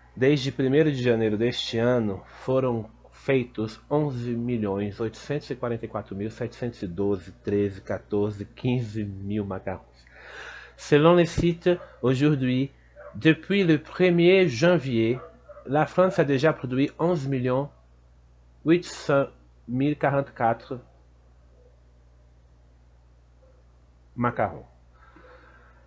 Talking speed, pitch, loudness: 65 wpm, 115 Hz, -25 LUFS